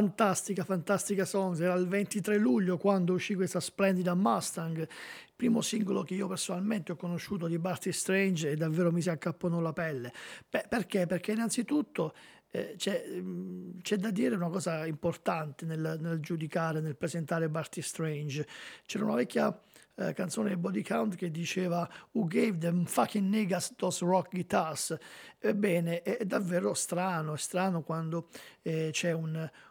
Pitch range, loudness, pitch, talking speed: 165-195 Hz, -32 LUFS, 180 Hz, 160 wpm